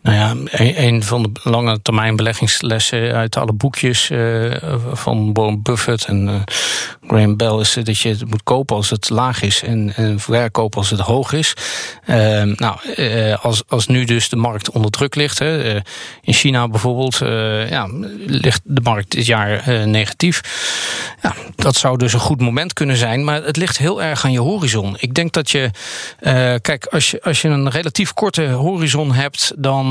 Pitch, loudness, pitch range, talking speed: 120 Hz, -16 LUFS, 110-140 Hz, 170 wpm